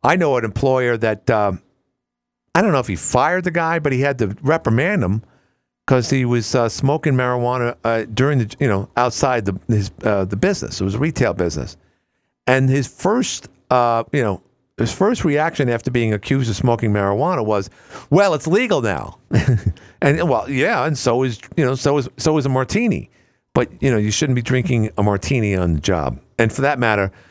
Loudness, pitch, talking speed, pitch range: -18 LUFS, 120 Hz, 200 wpm, 105-135 Hz